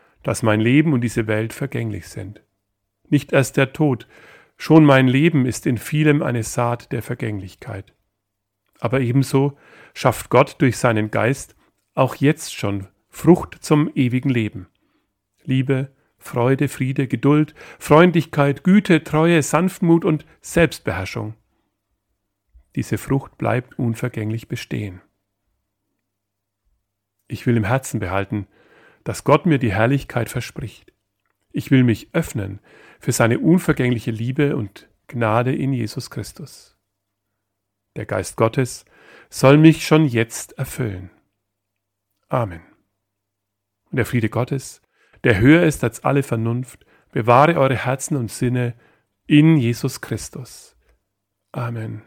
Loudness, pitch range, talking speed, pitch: -19 LUFS, 100-140 Hz, 120 wpm, 120 Hz